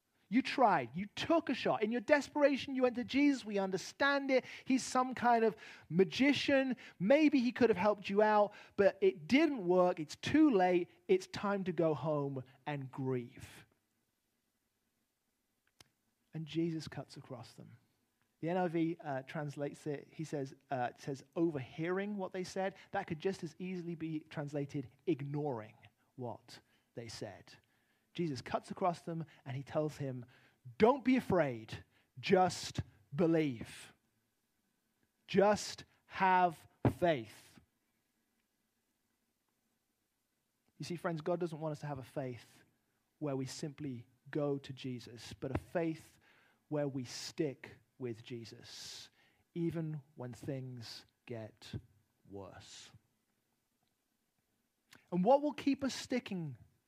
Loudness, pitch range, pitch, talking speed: -35 LUFS, 130-195 Hz, 155 Hz, 130 wpm